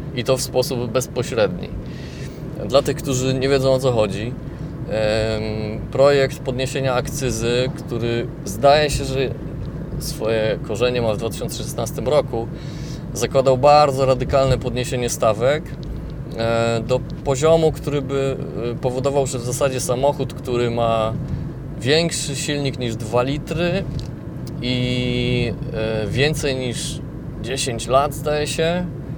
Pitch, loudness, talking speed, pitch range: 135 Hz, -20 LUFS, 110 wpm, 125-145 Hz